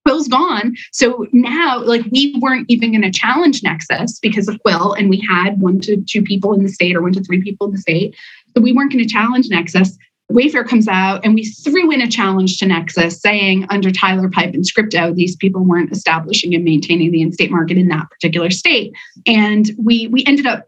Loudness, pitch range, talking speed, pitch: -14 LUFS, 180-235 Hz, 220 wpm, 200 Hz